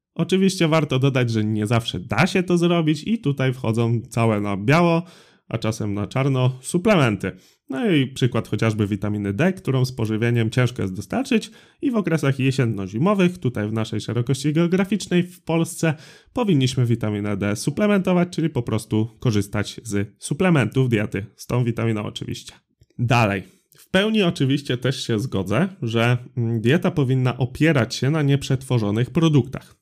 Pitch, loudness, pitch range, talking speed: 130 Hz, -21 LUFS, 110-165 Hz, 150 wpm